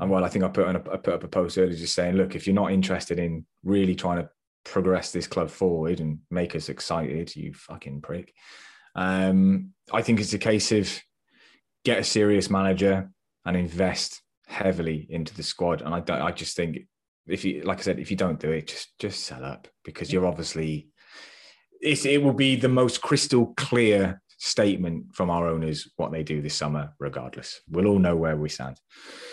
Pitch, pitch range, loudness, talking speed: 95 Hz, 80-100 Hz, -25 LUFS, 205 wpm